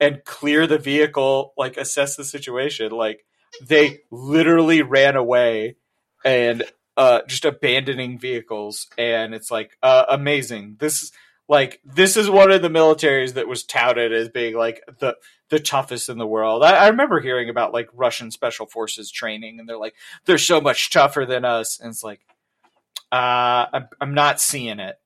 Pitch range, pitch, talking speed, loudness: 115-145 Hz, 125 Hz, 170 wpm, -18 LUFS